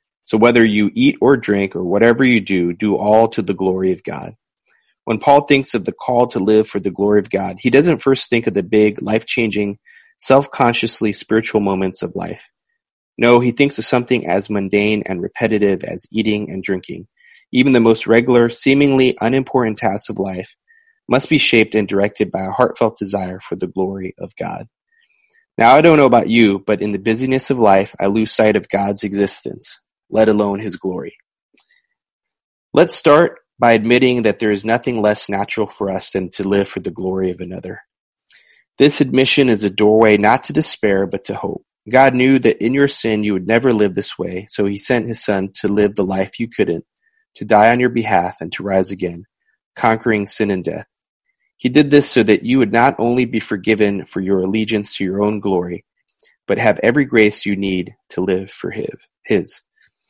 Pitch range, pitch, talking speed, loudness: 100-125 Hz, 110 Hz, 195 wpm, -15 LUFS